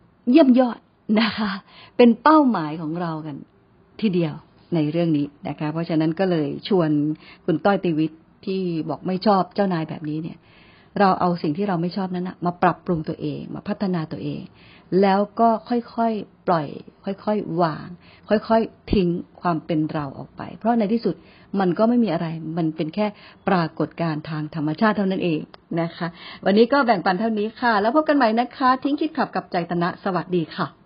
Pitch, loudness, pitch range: 185 Hz, -22 LUFS, 165-215 Hz